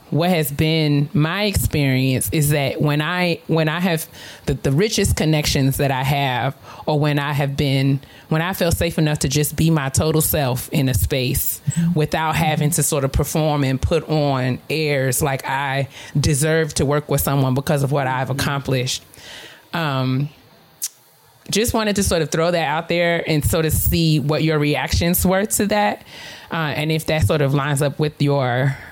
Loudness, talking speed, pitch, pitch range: -19 LUFS, 185 wpm, 150 Hz, 140-160 Hz